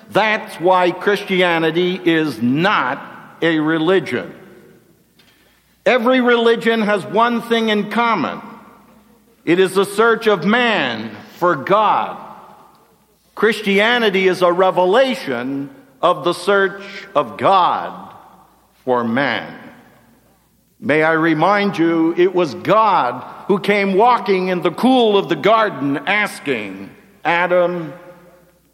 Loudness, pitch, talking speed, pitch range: -16 LUFS, 195 Hz, 105 wpm, 175-225 Hz